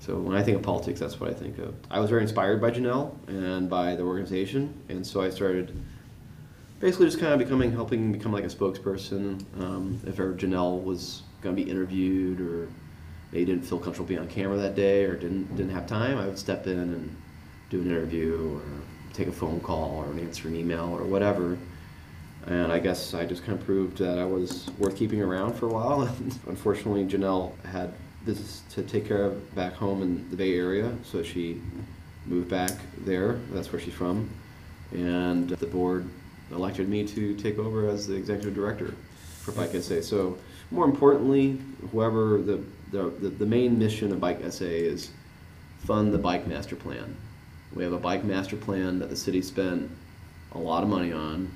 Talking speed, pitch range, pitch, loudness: 195 wpm, 90-100 Hz, 95 Hz, -28 LUFS